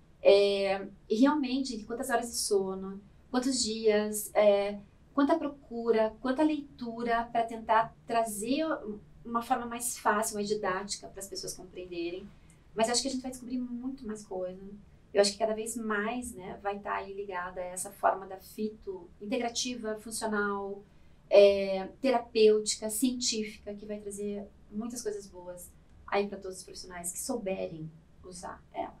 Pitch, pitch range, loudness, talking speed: 215 Hz, 200-235 Hz, -31 LUFS, 155 wpm